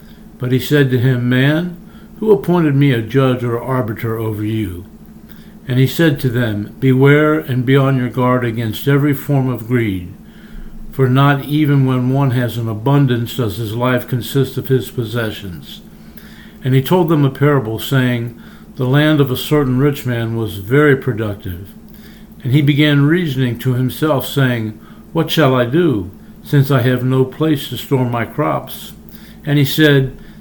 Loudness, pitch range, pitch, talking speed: -15 LUFS, 120-150 Hz, 130 Hz, 170 wpm